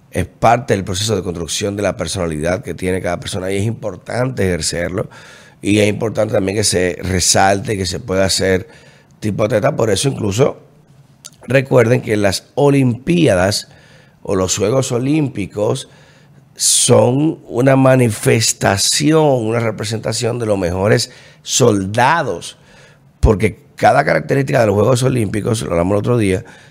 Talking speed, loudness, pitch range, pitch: 140 wpm, -15 LUFS, 95-130 Hz, 110 Hz